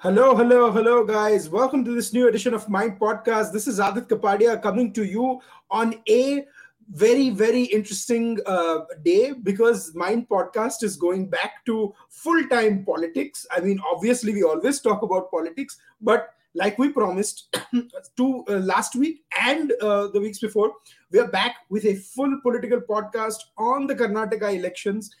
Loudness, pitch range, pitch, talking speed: -22 LUFS, 205-245 Hz, 225 Hz, 160 wpm